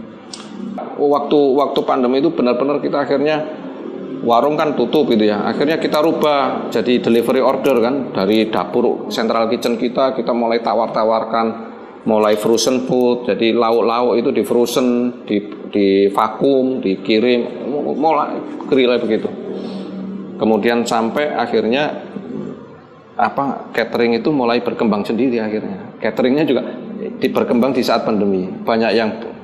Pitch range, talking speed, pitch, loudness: 115-135 Hz, 125 wpm, 120 Hz, -16 LUFS